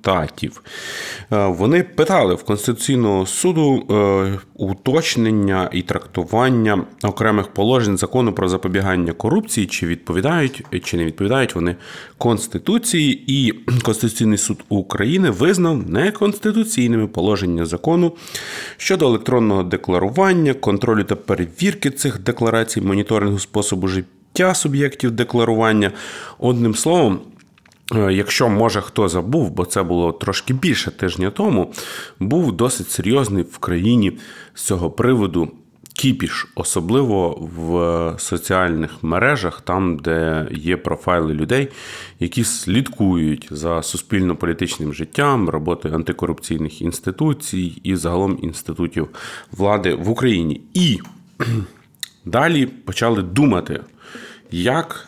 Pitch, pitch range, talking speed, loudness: 100 Hz, 90-125 Hz, 100 wpm, -18 LUFS